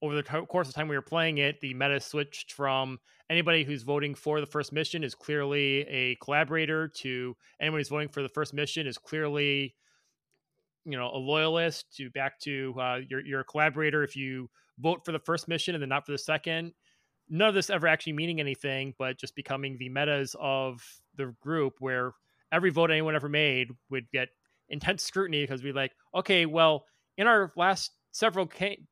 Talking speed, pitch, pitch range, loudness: 200 wpm, 145 Hz, 135-160 Hz, -29 LUFS